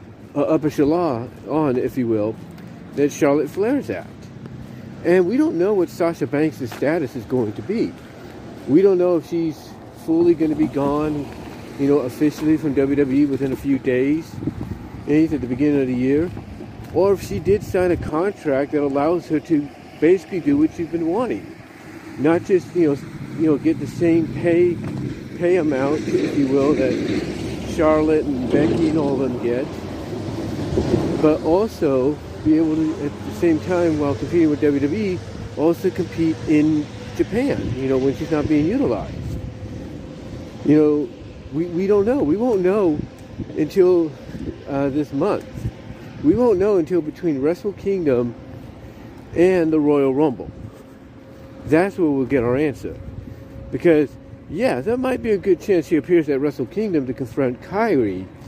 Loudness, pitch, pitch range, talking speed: -20 LUFS, 150 Hz, 130-170 Hz, 160 wpm